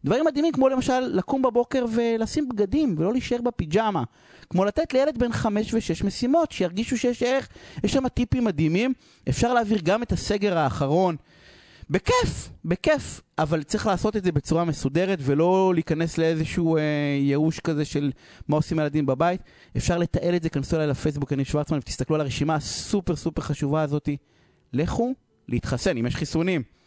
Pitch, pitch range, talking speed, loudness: 175 Hz, 150-235 Hz, 165 wpm, -24 LUFS